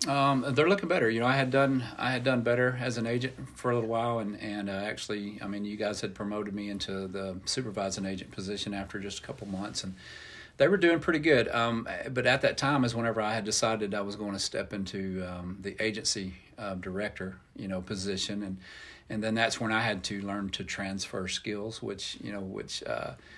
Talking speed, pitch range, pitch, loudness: 225 wpm, 100-115 Hz, 105 Hz, -31 LUFS